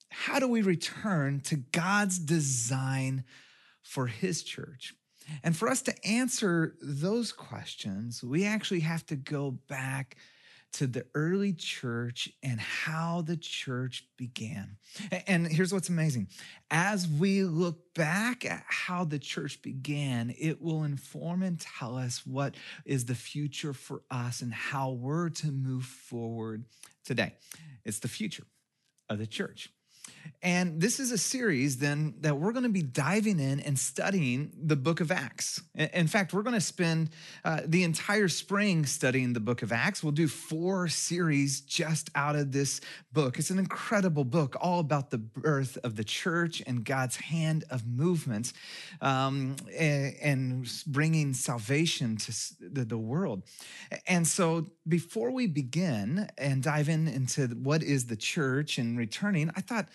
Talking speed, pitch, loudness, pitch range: 155 wpm, 155 Hz, -31 LUFS, 130-180 Hz